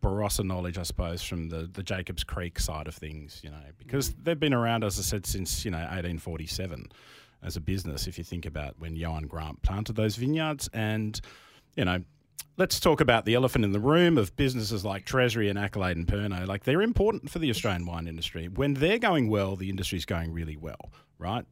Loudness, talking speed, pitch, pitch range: -29 LUFS, 210 wpm, 95 Hz, 85-115 Hz